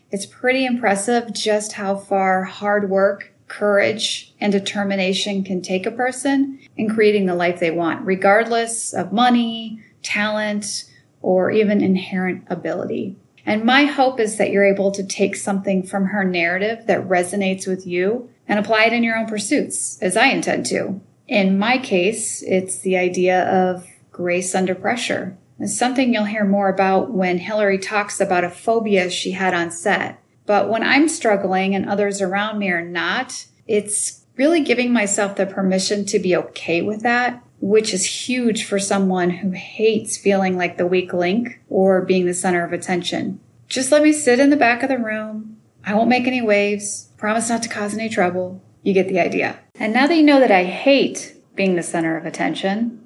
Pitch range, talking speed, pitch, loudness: 185-225 Hz, 180 wpm, 200 Hz, -19 LUFS